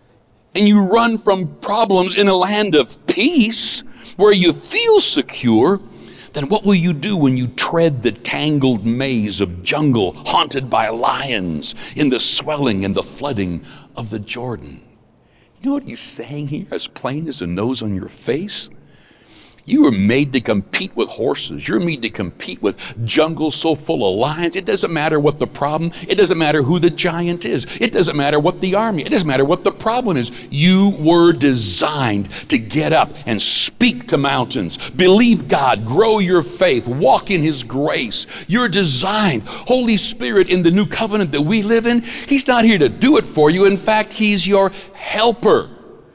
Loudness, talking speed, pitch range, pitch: -15 LUFS, 180 wpm, 135-210 Hz, 170 Hz